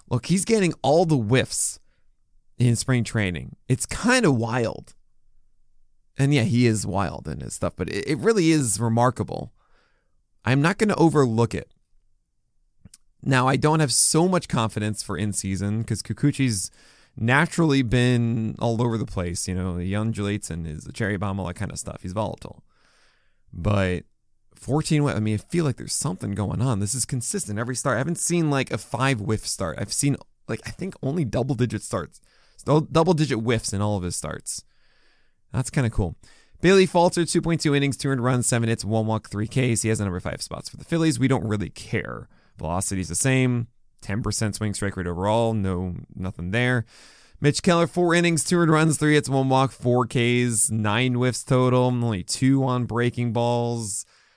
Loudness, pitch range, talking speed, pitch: -23 LUFS, 105-140 Hz, 190 wpm, 120 Hz